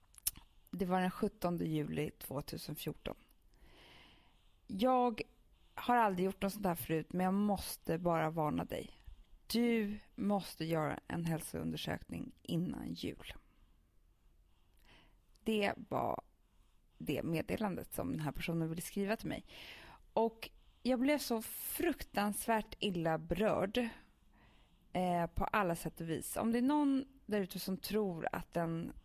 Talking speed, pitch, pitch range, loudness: 130 wpm, 185 Hz, 155-215 Hz, -38 LUFS